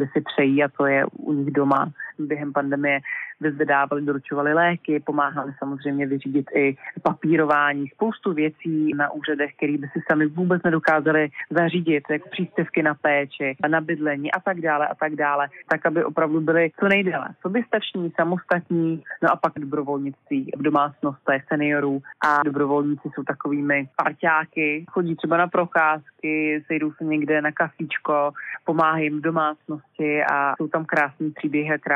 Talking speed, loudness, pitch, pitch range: 150 wpm, -22 LUFS, 150 Hz, 145-165 Hz